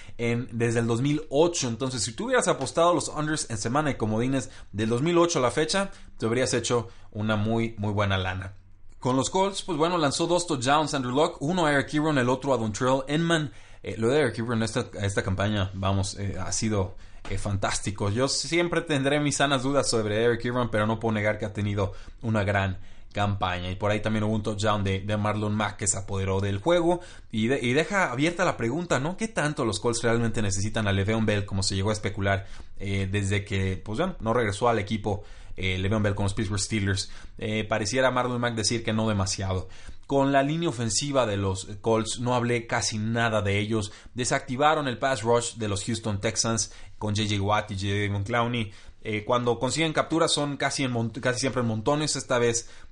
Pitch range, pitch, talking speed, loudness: 100-135 Hz, 115 Hz, 205 wpm, -26 LUFS